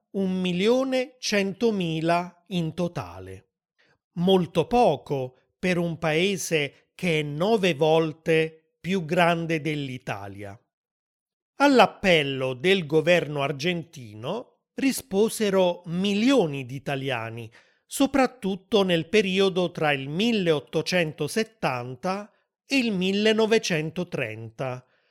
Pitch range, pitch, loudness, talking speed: 150-195 Hz, 170 Hz, -24 LUFS, 80 wpm